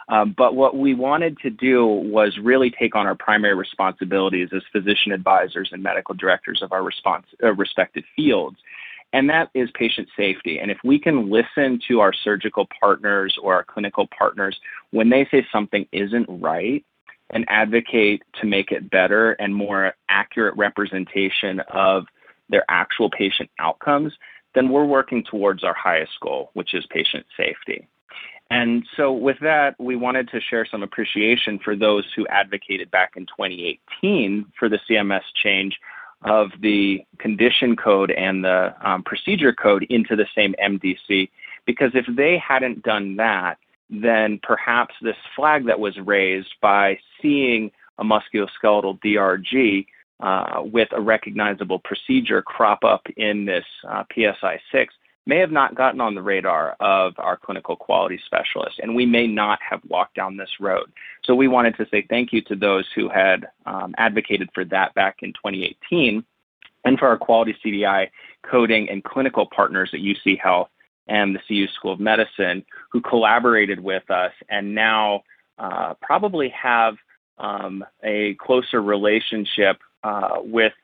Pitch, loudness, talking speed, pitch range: 105 Hz, -20 LUFS, 155 wpm, 100-120 Hz